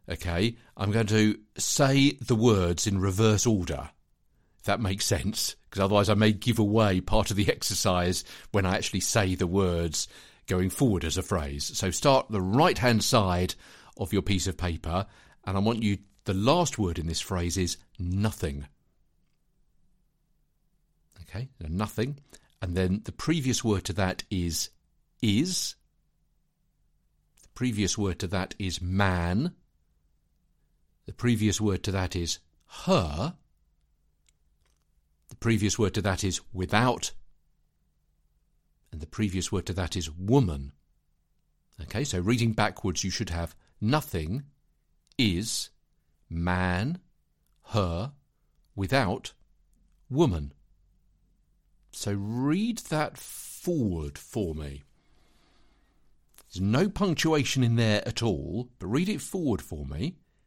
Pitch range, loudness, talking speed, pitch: 90-115 Hz, -28 LUFS, 130 wpm, 100 Hz